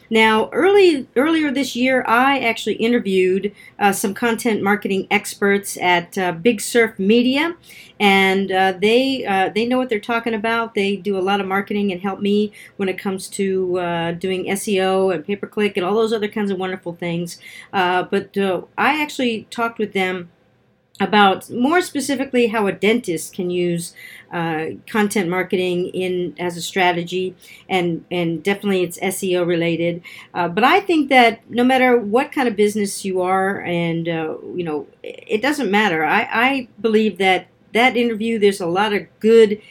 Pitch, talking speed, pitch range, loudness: 200 Hz, 170 wpm, 185-230 Hz, -18 LUFS